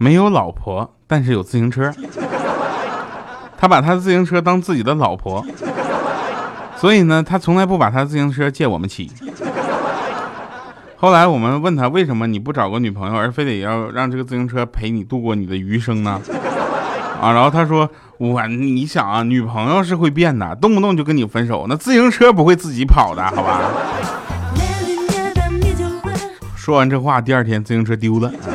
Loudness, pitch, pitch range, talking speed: -16 LUFS, 130 Hz, 115-165 Hz, 255 characters per minute